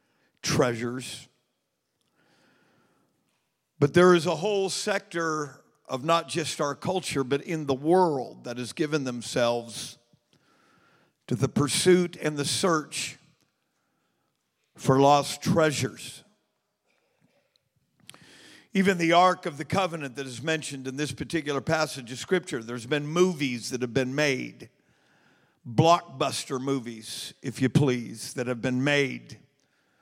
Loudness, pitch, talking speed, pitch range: -26 LUFS, 145 Hz, 120 wpm, 130-165 Hz